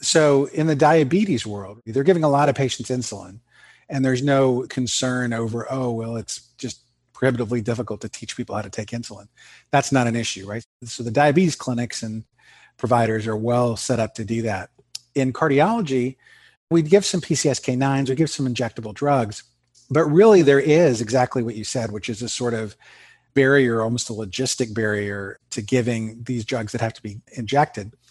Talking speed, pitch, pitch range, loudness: 185 wpm, 125 Hz, 115-135 Hz, -21 LUFS